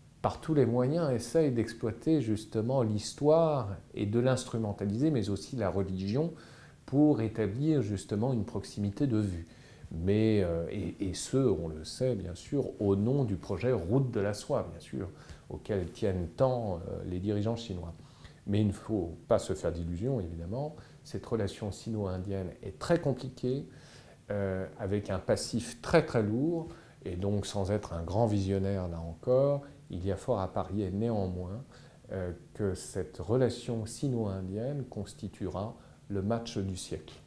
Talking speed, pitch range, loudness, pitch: 155 wpm, 100-130 Hz, -32 LUFS, 110 Hz